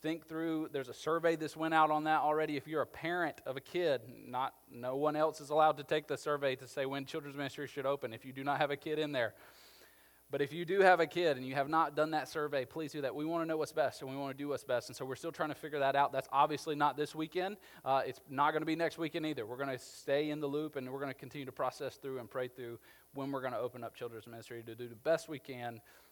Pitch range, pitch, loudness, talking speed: 135-155 Hz, 145 Hz, -36 LUFS, 295 wpm